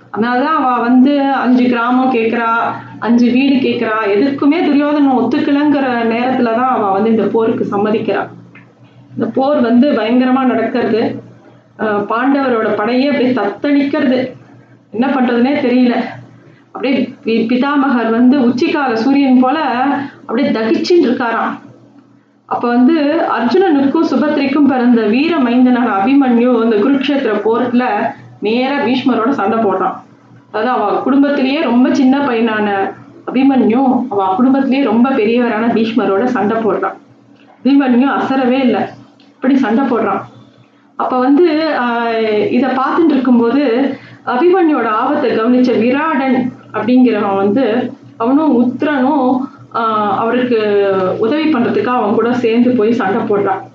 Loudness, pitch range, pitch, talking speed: -13 LUFS, 225-270 Hz, 250 Hz, 110 wpm